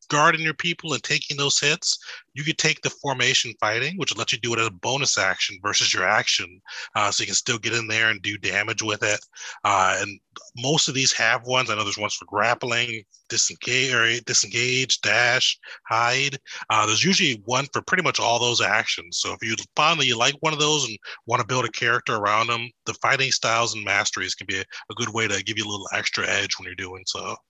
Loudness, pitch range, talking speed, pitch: -22 LUFS, 110-135 Hz, 230 wpm, 120 Hz